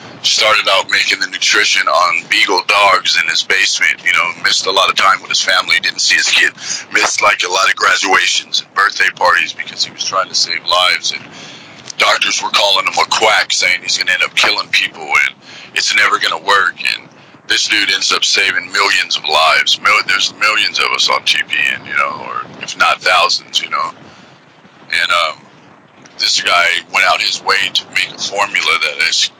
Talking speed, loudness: 200 wpm, -11 LUFS